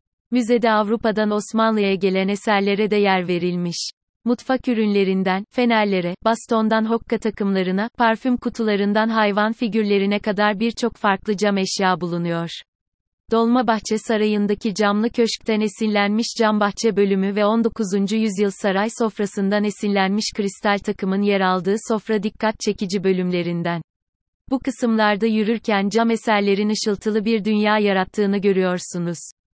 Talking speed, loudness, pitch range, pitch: 115 wpm, -20 LUFS, 195-225 Hz, 210 Hz